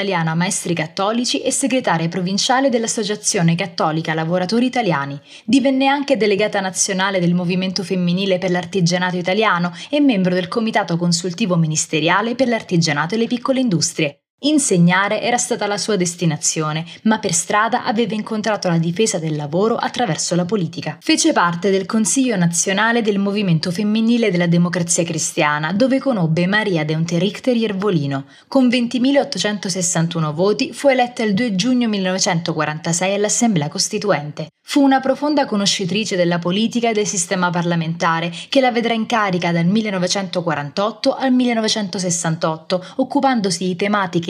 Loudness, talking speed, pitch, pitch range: -18 LUFS, 135 wpm, 195 Hz, 175-225 Hz